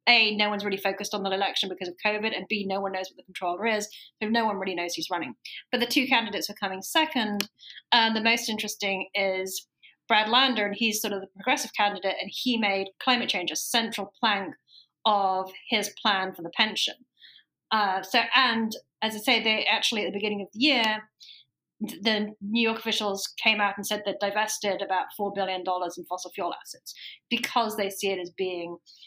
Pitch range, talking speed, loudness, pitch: 195-225 Hz, 205 wpm, -26 LUFS, 205 Hz